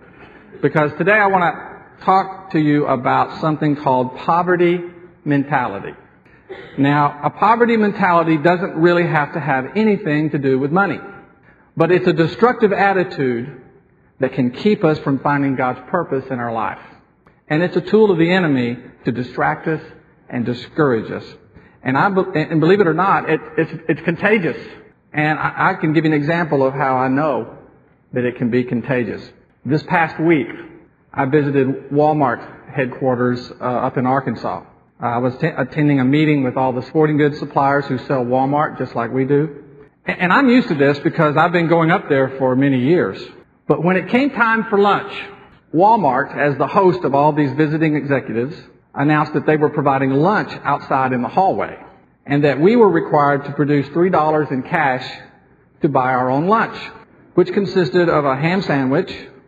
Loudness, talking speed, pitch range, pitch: -17 LUFS, 180 wpm, 135-175 Hz, 150 Hz